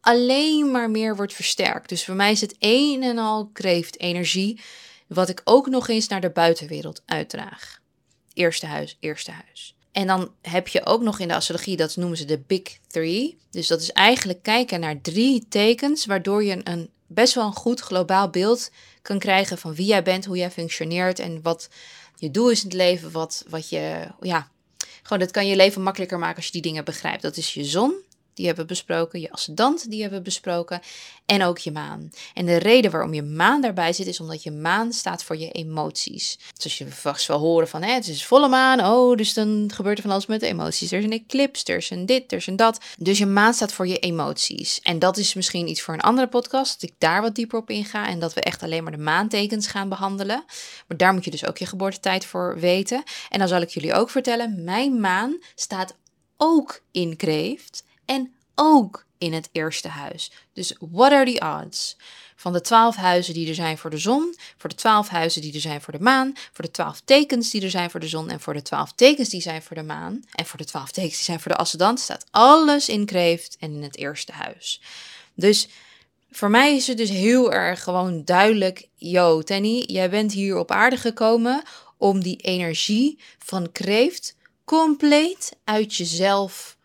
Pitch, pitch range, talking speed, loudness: 195 Hz, 170-235 Hz, 215 wpm, -21 LUFS